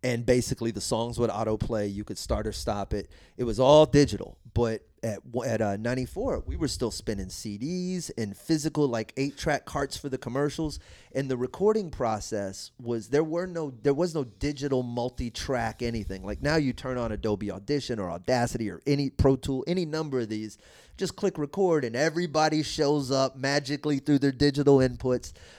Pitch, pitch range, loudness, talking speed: 130 Hz, 110-145 Hz, -28 LUFS, 185 wpm